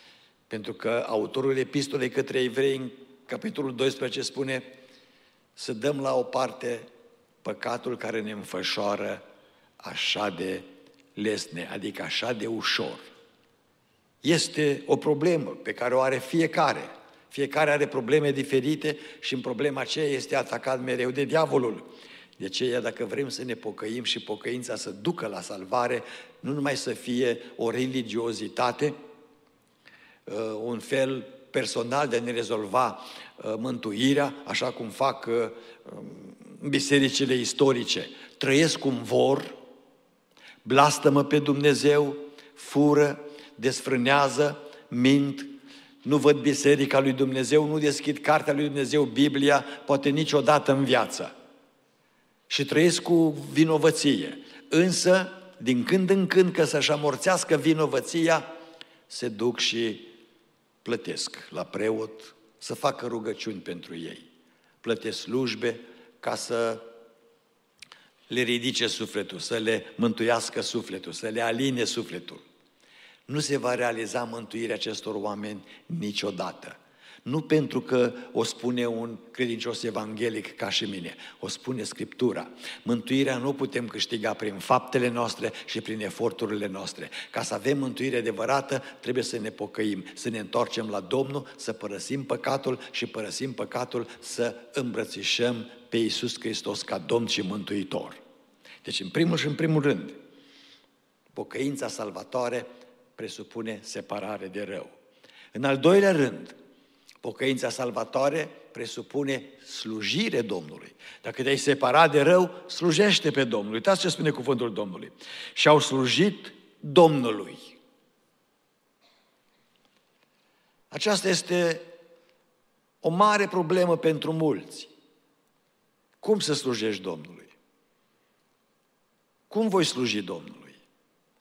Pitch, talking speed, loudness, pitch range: 130 Hz, 120 wpm, -26 LUFS, 115-150 Hz